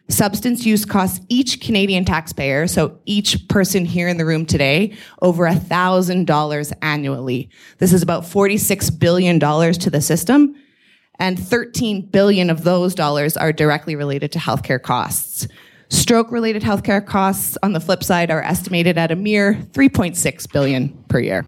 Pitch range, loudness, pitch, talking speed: 150-200 Hz, -17 LUFS, 175 Hz, 150 wpm